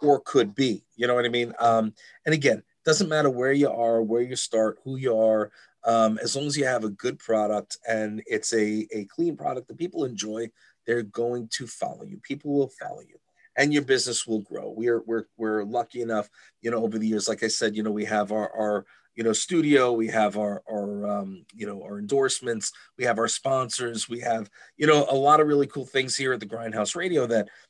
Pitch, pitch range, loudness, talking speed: 115 Hz, 110-130 Hz, -25 LUFS, 230 wpm